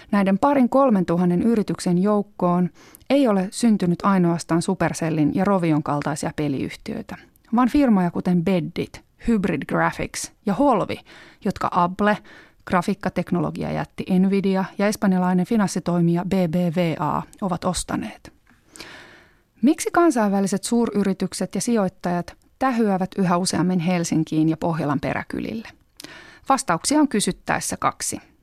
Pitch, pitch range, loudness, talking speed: 185 Hz, 175-210 Hz, -21 LUFS, 105 wpm